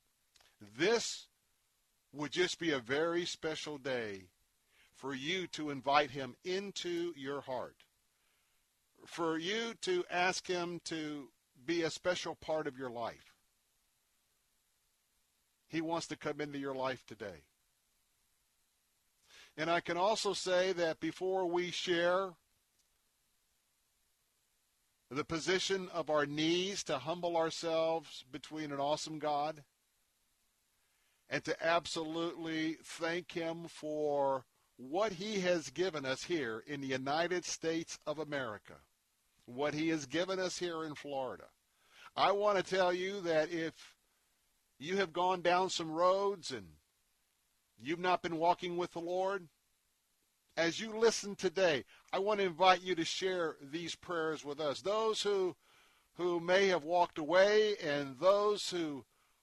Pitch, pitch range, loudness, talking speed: 165 Hz, 150-180 Hz, -36 LUFS, 130 wpm